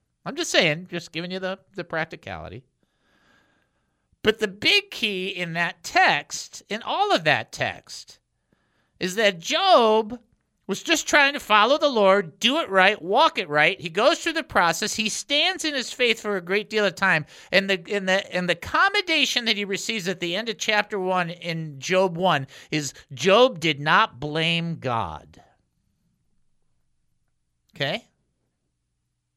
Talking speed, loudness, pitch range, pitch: 160 wpm, -22 LUFS, 170-230 Hz, 195 Hz